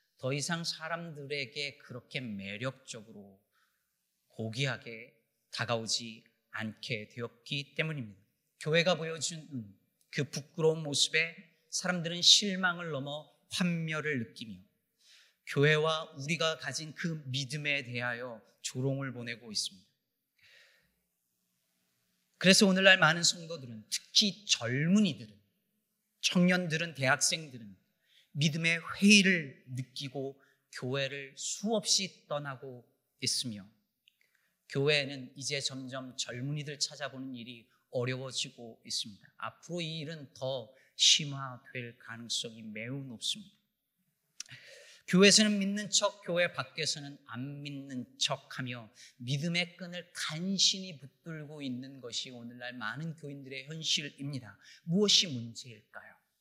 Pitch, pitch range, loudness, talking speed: 140 Hz, 125-170 Hz, -31 LUFS, 255 characters per minute